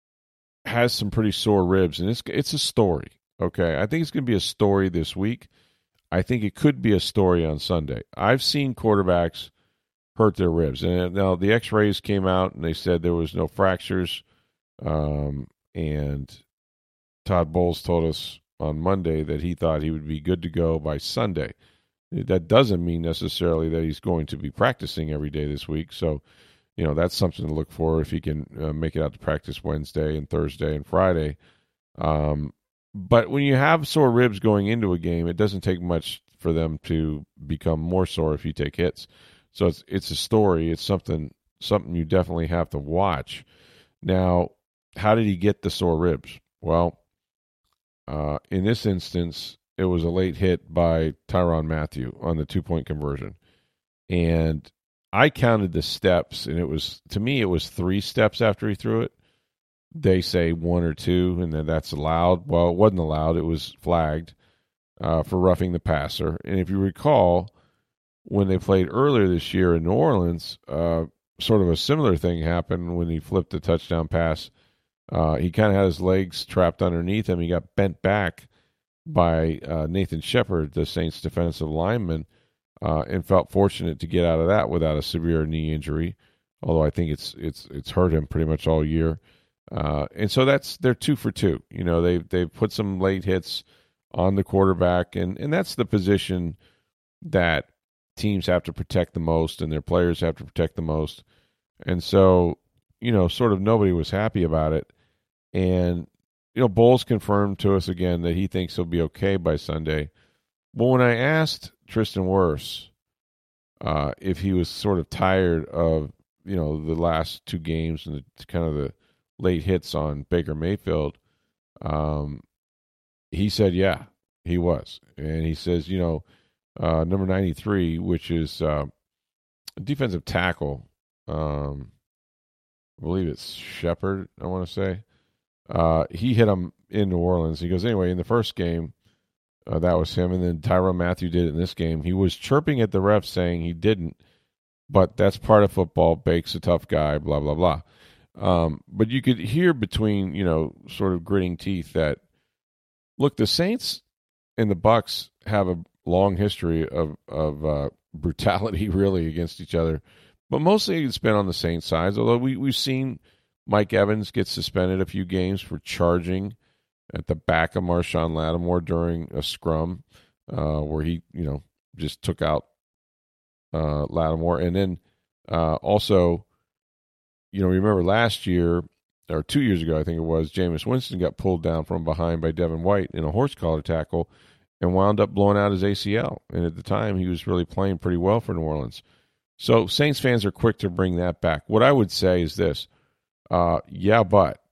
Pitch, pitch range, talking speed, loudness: 90 Hz, 80-100 Hz, 185 wpm, -24 LUFS